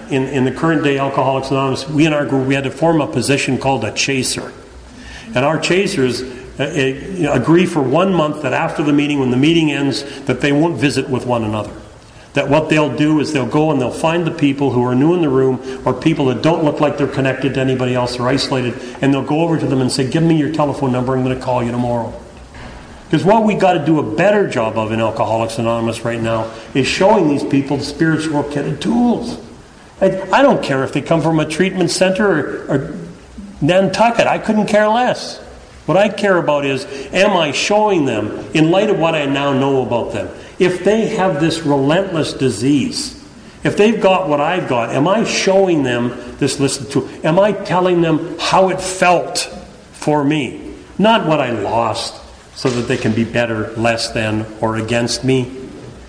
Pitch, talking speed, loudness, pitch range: 140 Hz, 210 wpm, -15 LUFS, 130-165 Hz